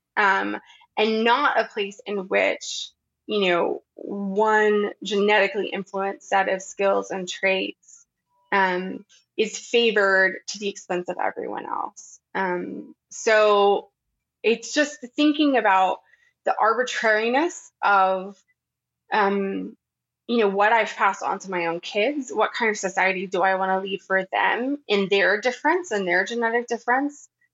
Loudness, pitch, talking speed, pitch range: -22 LUFS, 205 Hz, 140 wpm, 190-240 Hz